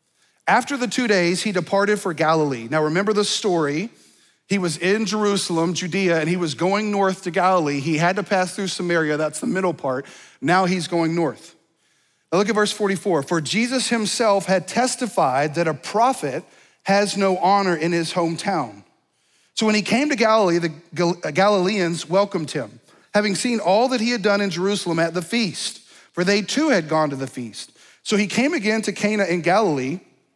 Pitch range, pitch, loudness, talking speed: 170-210 Hz, 190 Hz, -20 LUFS, 190 wpm